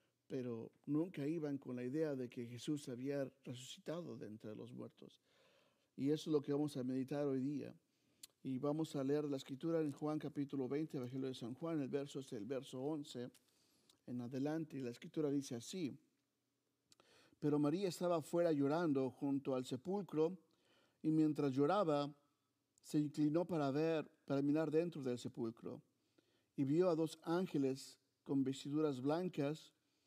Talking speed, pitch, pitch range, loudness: 160 wpm, 145 Hz, 130-155 Hz, -41 LUFS